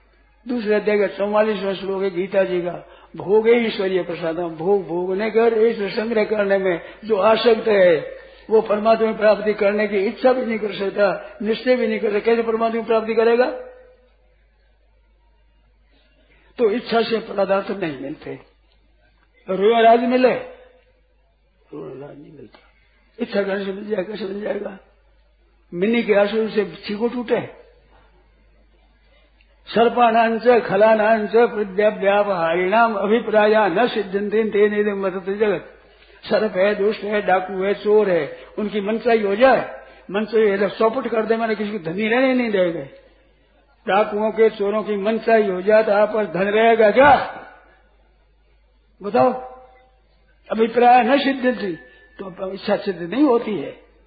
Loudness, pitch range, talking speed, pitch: -19 LUFS, 200-230 Hz, 140 wpm, 215 Hz